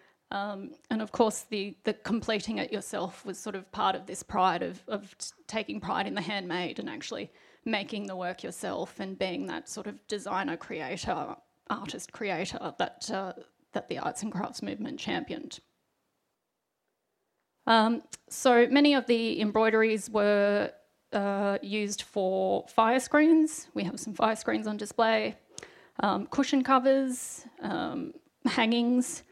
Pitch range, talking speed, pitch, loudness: 205-255 Hz, 145 wpm, 220 Hz, -29 LUFS